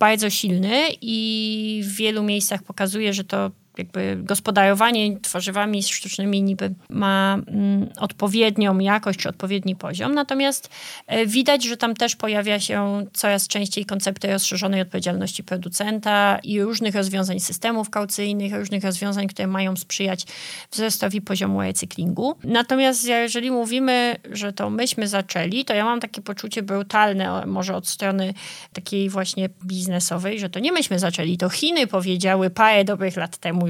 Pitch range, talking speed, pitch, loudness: 190-215 Hz, 135 wpm, 200 Hz, -22 LUFS